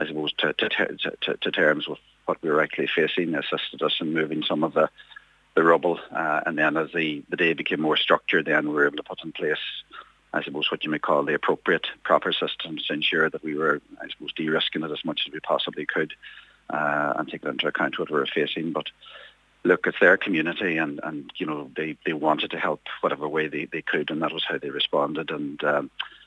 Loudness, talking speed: -25 LUFS, 235 wpm